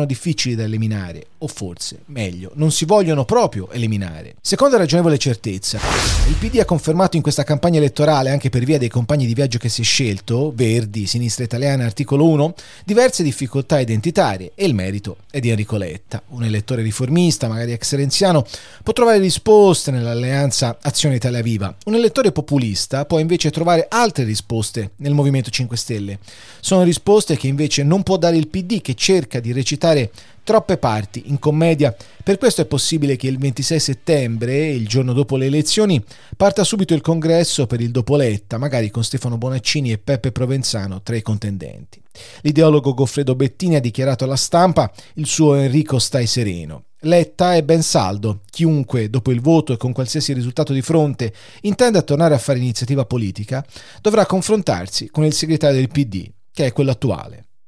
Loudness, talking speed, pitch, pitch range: -17 LUFS, 170 wpm, 135 Hz, 115-160 Hz